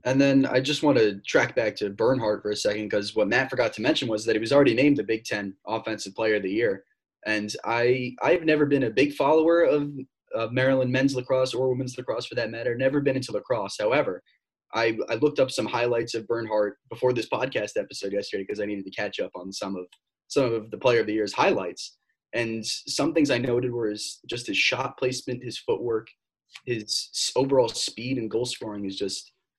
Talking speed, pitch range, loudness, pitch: 220 wpm, 105-135 Hz, -25 LUFS, 120 Hz